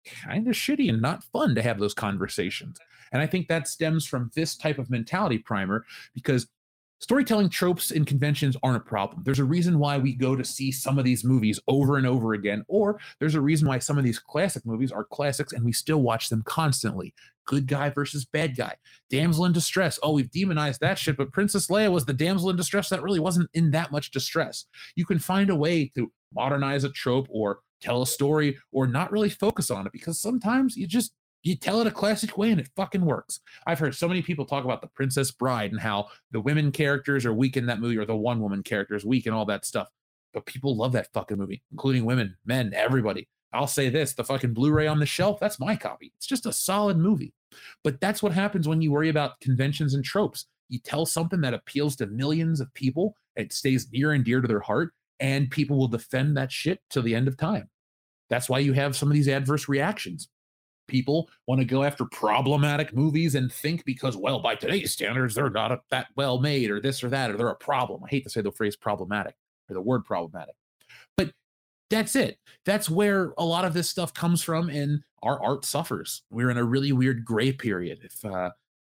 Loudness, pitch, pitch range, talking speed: -26 LUFS, 140 Hz, 125-165 Hz, 220 wpm